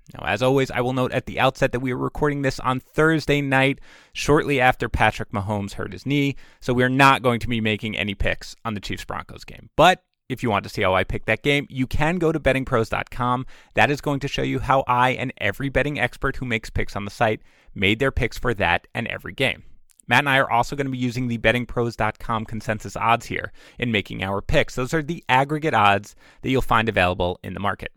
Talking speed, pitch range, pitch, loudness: 240 wpm, 110-135 Hz, 125 Hz, -22 LUFS